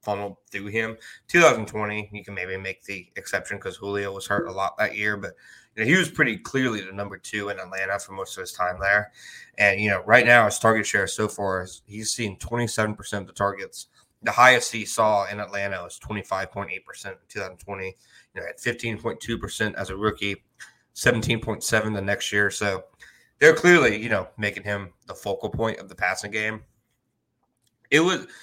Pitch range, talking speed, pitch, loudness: 100-110 Hz, 195 wpm, 105 Hz, -23 LUFS